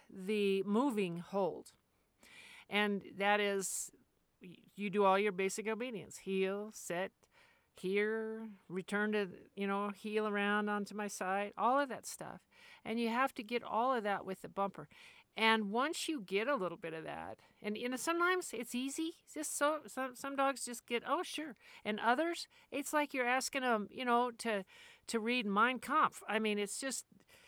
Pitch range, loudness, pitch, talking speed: 200-265 Hz, -37 LUFS, 220 Hz, 180 wpm